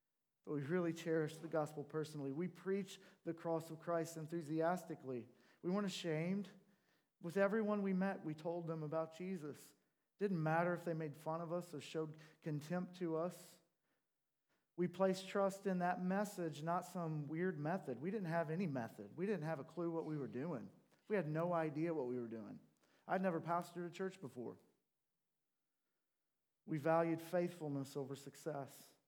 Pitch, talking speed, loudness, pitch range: 165 Hz, 170 wpm, -43 LUFS, 155-180 Hz